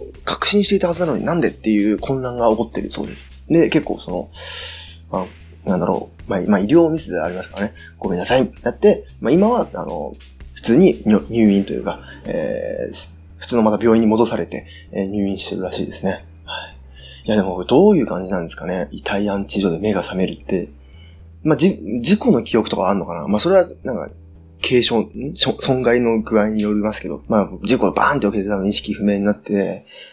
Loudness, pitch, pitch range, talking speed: -18 LUFS, 100 Hz, 80-115 Hz, 400 characters per minute